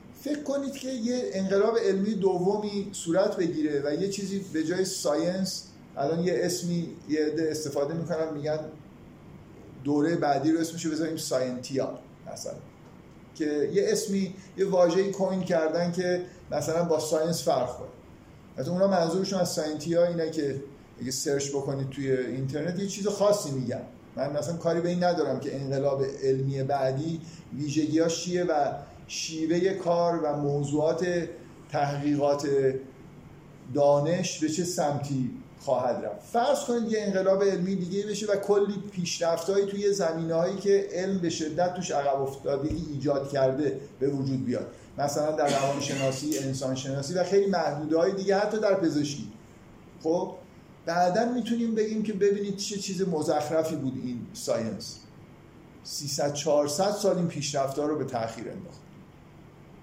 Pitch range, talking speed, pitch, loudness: 145-190 Hz, 140 wpm, 165 Hz, -28 LUFS